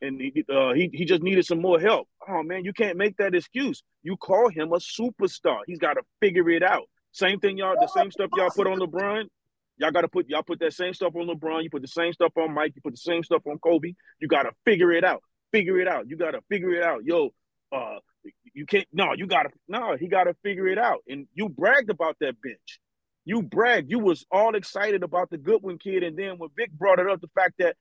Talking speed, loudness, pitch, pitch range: 255 wpm, -24 LUFS, 185 Hz, 170-205 Hz